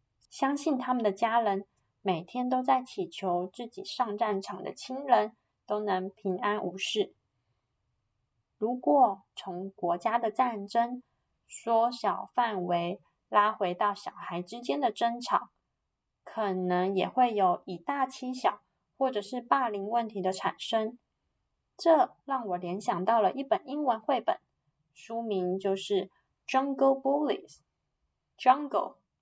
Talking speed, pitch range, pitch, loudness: 215 characters per minute, 185-255 Hz, 210 Hz, -30 LUFS